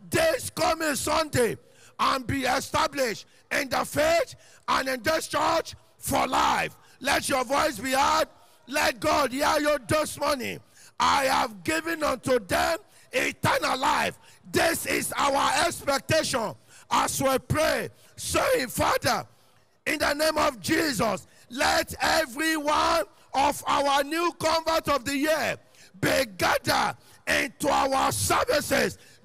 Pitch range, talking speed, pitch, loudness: 280-320 Hz, 125 wpm, 310 Hz, -25 LUFS